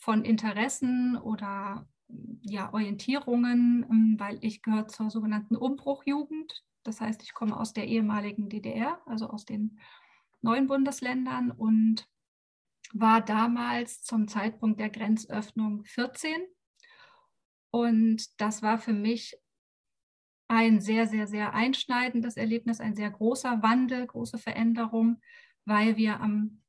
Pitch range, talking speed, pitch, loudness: 215-245 Hz, 115 wpm, 225 Hz, -29 LUFS